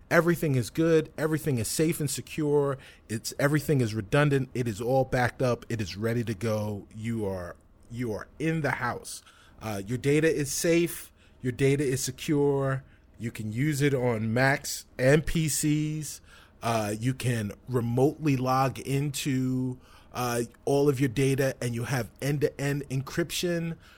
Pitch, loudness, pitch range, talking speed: 130 Hz, -28 LUFS, 115-145 Hz, 155 wpm